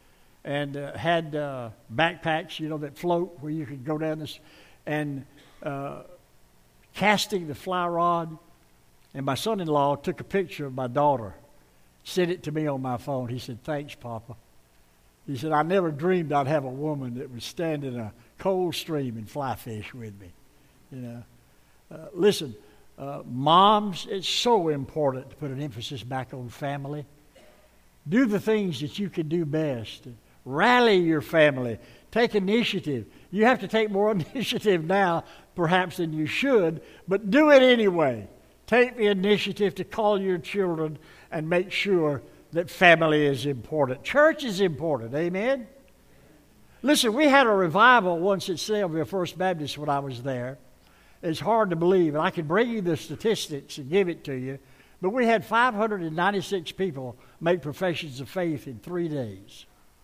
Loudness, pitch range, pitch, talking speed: -25 LUFS, 135-190 Hz, 155 Hz, 170 wpm